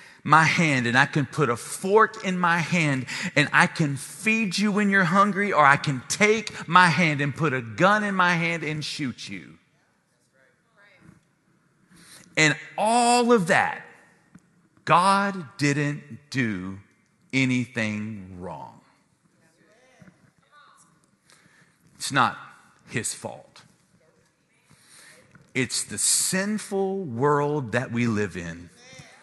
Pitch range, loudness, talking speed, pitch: 135-190 Hz, -22 LUFS, 115 wpm, 160 Hz